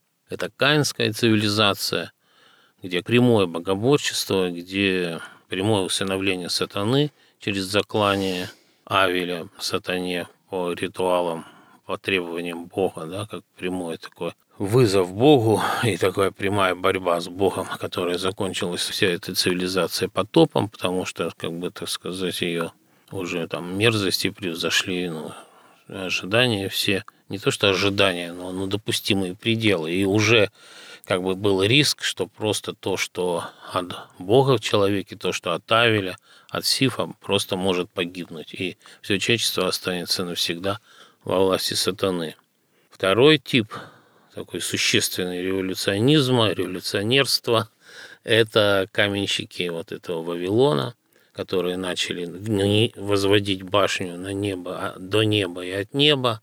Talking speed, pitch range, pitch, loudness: 120 wpm, 90-105 Hz, 95 Hz, -22 LUFS